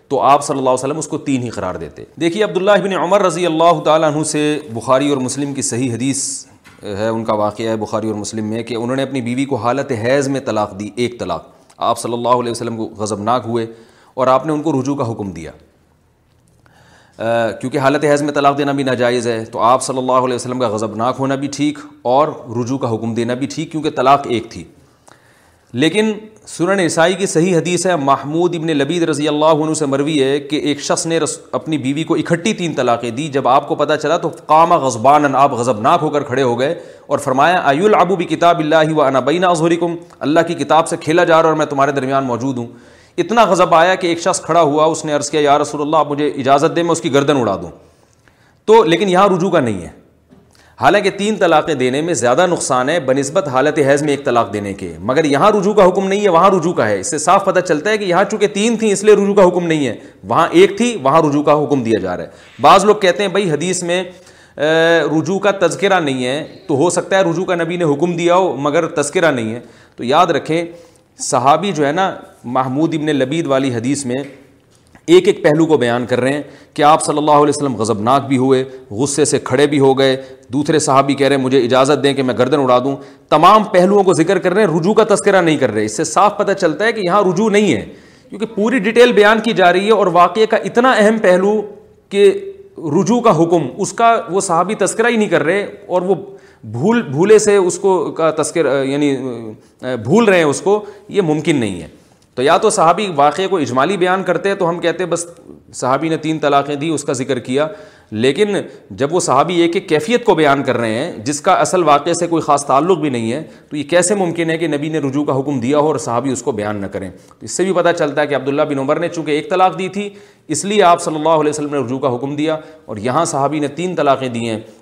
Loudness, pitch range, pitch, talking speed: -14 LUFS, 130-180 Hz, 150 Hz, 240 wpm